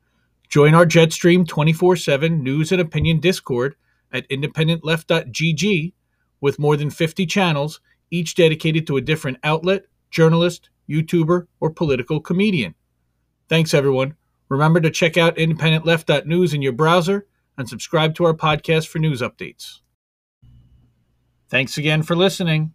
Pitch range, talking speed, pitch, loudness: 140-170 Hz, 130 wpm, 160 Hz, -18 LUFS